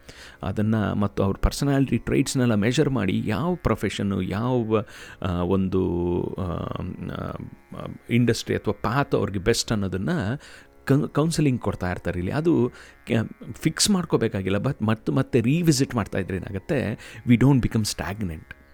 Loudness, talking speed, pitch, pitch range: -24 LUFS, 110 wpm, 110 Hz, 95-130 Hz